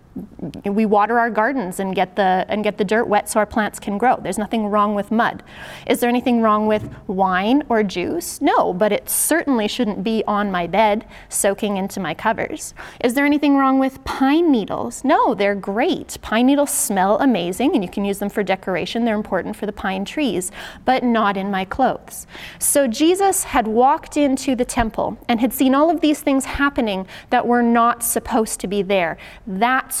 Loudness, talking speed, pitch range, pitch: -19 LUFS, 195 wpm, 205-260 Hz, 225 Hz